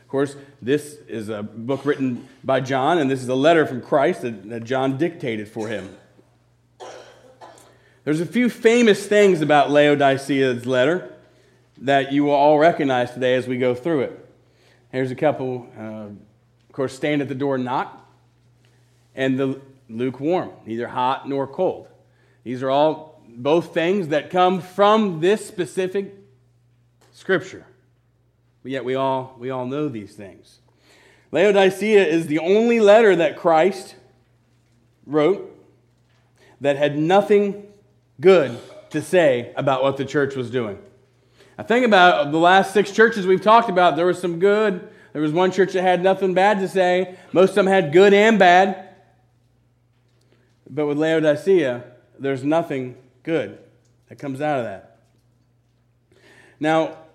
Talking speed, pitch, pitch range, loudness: 145 wpm, 135 Hz, 125-180 Hz, -19 LUFS